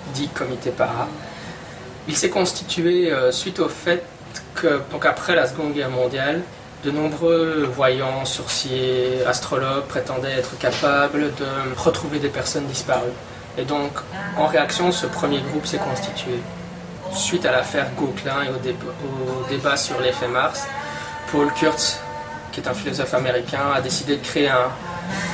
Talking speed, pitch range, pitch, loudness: 145 wpm, 130-160 Hz, 140 Hz, -21 LUFS